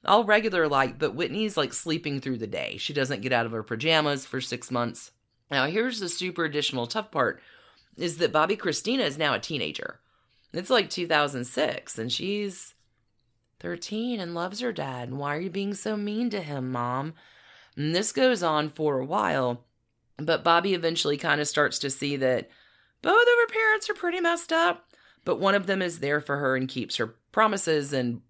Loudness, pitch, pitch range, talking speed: -26 LUFS, 155 Hz, 130-200 Hz, 195 wpm